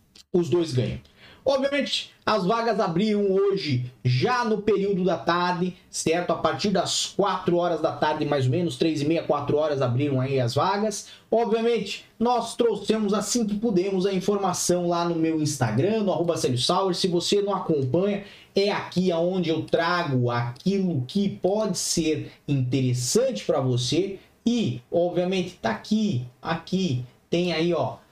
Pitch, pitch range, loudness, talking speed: 175 Hz, 155-200 Hz, -24 LUFS, 150 wpm